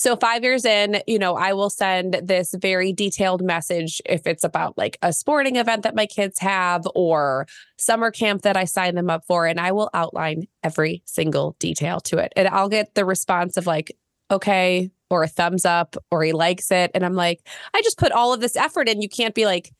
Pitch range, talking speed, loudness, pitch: 175-210 Hz, 220 wpm, -21 LUFS, 190 Hz